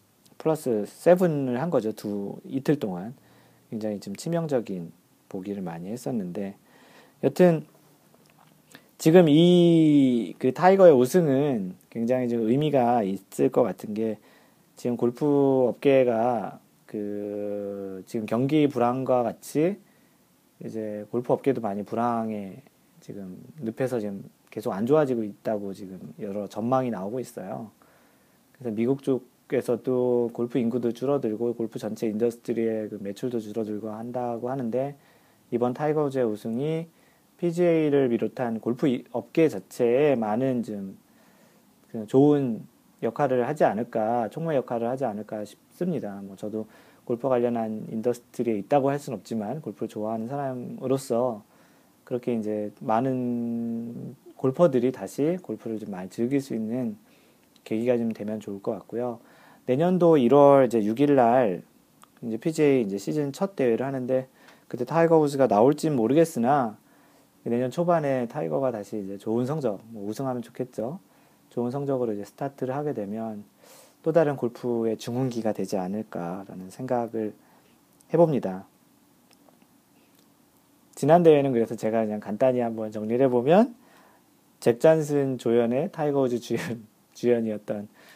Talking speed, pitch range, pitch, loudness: 290 characters per minute, 110-140 Hz, 120 Hz, -25 LUFS